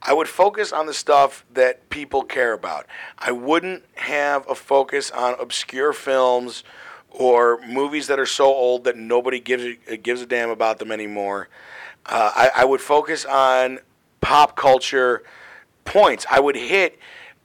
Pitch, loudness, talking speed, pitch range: 130 Hz, -19 LUFS, 160 wpm, 120-145 Hz